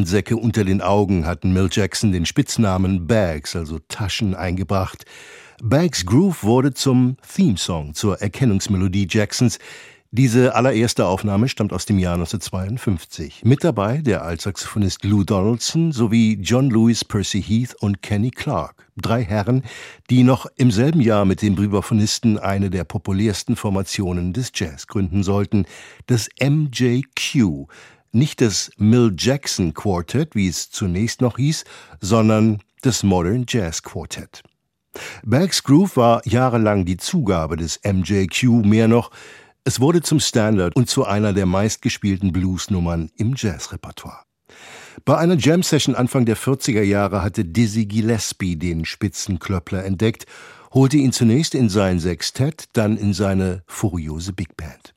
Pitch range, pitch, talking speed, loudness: 95-125 Hz, 110 Hz, 140 wpm, -19 LUFS